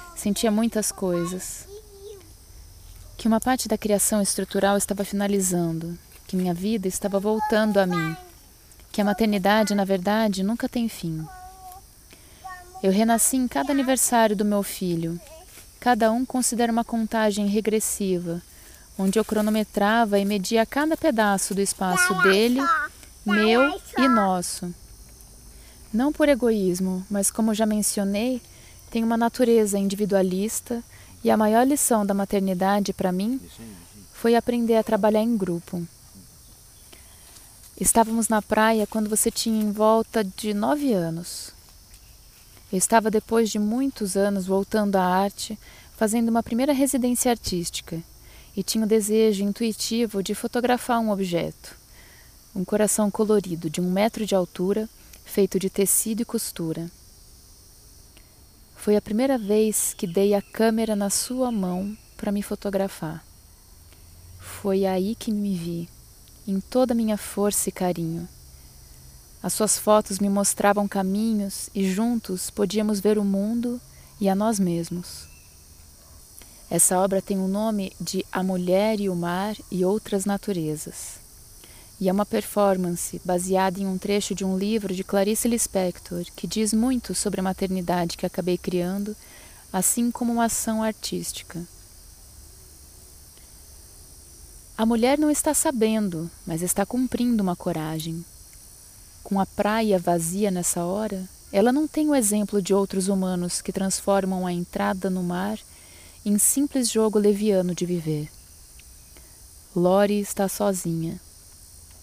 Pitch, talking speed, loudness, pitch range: 200 Hz, 135 wpm, -23 LUFS, 180-220 Hz